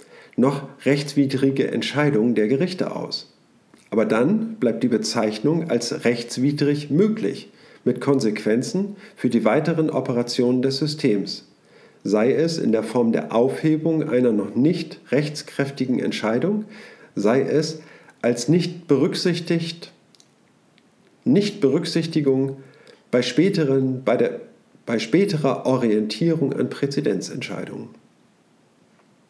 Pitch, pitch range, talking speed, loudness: 140 Hz, 125-165 Hz, 95 wpm, -22 LUFS